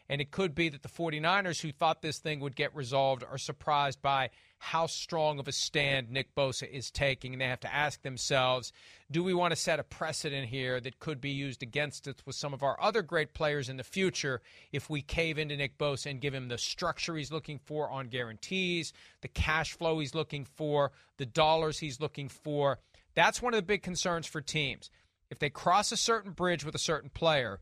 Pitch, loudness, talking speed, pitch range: 145 Hz, -32 LUFS, 220 wpm, 135-160 Hz